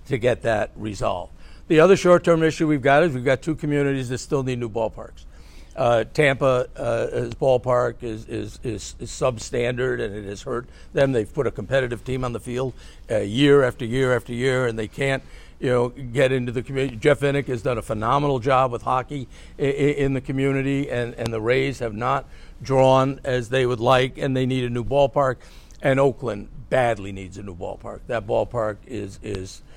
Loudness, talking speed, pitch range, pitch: -22 LUFS, 200 wpm, 120-135 Hz, 130 Hz